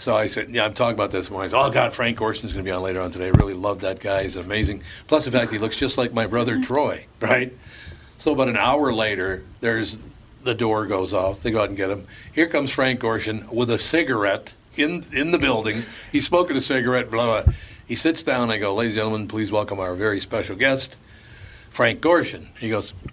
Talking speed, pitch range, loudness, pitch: 235 wpm, 100-120 Hz, -22 LUFS, 110 Hz